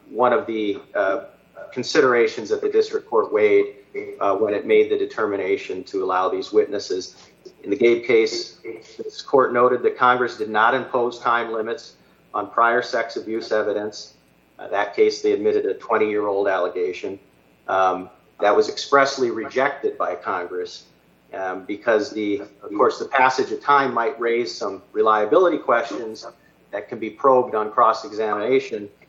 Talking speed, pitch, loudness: 155 wpm, 390 Hz, -21 LUFS